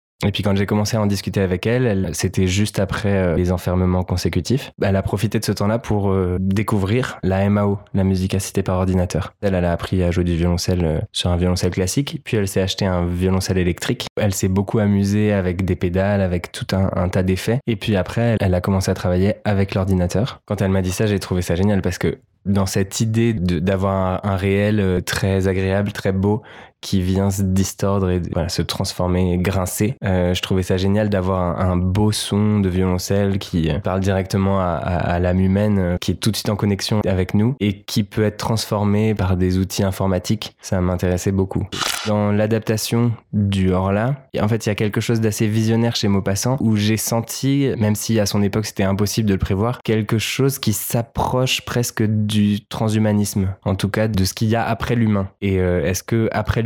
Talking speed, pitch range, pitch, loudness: 215 wpm, 95-110 Hz, 100 Hz, -19 LUFS